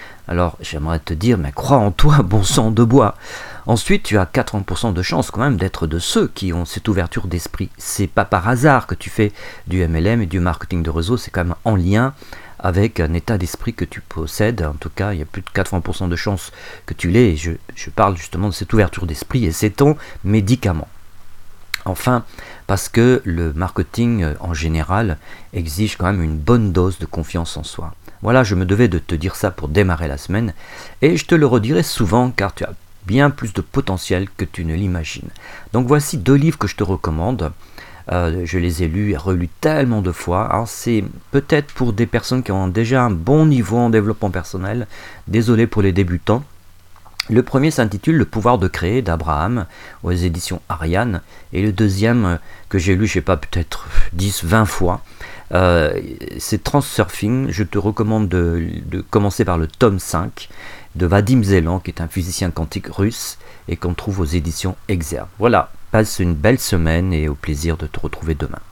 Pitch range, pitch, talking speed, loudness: 85-115 Hz, 95 Hz, 200 wpm, -18 LUFS